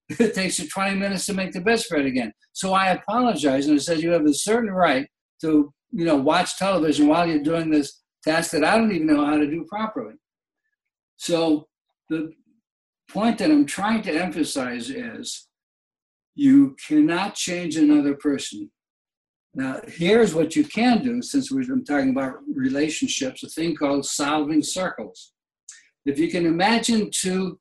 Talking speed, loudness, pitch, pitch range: 165 wpm, -22 LUFS, 185 Hz, 155-240 Hz